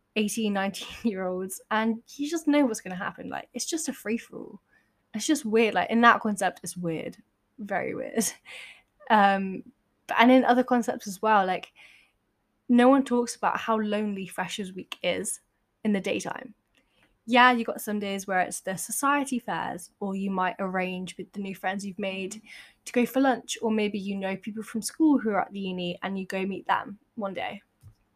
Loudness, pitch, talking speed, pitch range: -27 LUFS, 210 Hz, 190 wpm, 190-240 Hz